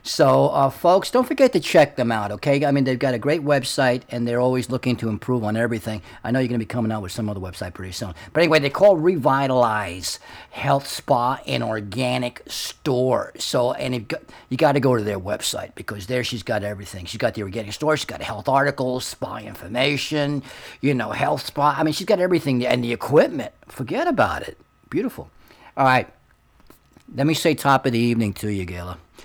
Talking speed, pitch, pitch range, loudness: 215 wpm, 125 Hz, 110-140 Hz, -21 LUFS